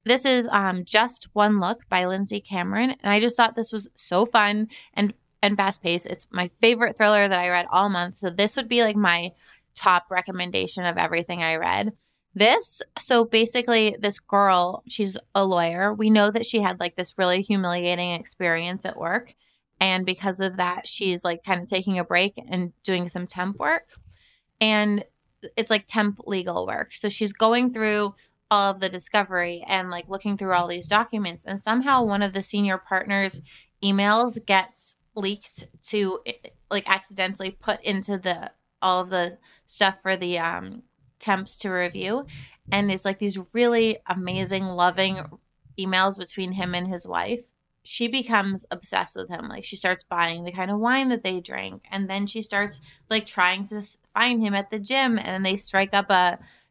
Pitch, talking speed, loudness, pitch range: 195 Hz, 180 wpm, -23 LUFS, 180-215 Hz